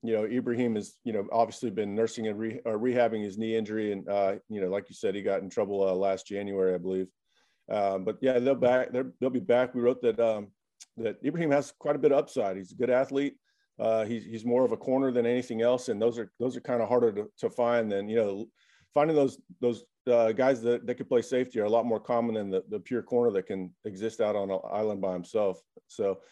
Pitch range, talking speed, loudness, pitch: 105-125 Hz, 255 wpm, -29 LUFS, 115 Hz